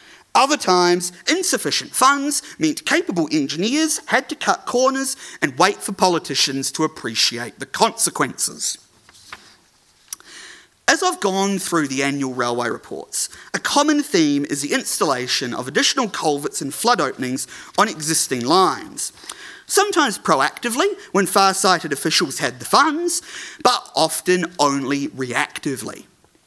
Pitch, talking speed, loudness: 195 Hz, 120 wpm, -19 LUFS